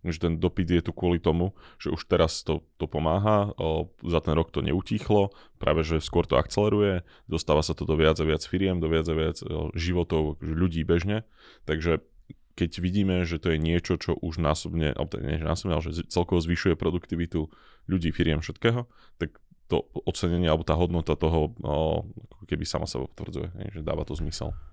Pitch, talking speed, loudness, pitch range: 85 Hz, 190 wpm, -27 LUFS, 80-90 Hz